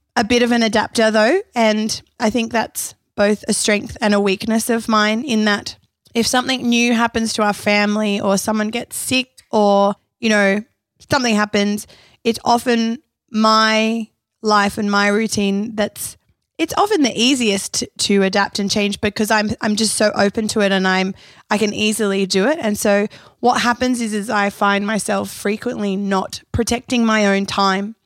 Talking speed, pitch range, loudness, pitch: 175 wpm, 205-230 Hz, -17 LUFS, 215 Hz